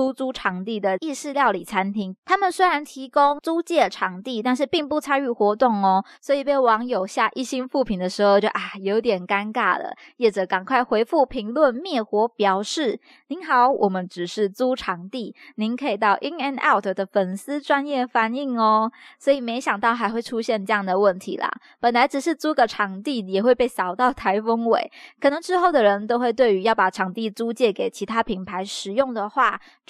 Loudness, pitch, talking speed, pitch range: -22 LUFS, 235 Hz, 300 characters per minute, 205-275 Hz